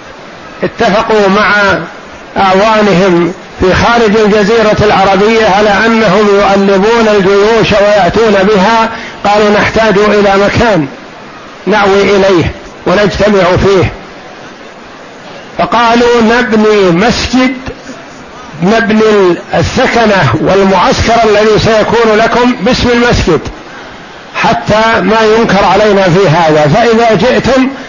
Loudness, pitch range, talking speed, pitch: -7 LUFS, 195-225 Hz, 85 wpm, 210 Hz